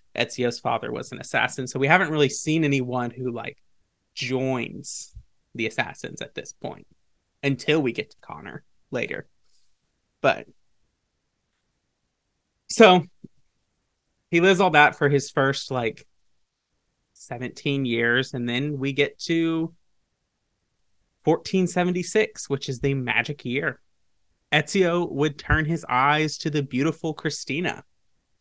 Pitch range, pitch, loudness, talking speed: 130-160 Hz, 140 Hz, -23 LUFS, 120 wpm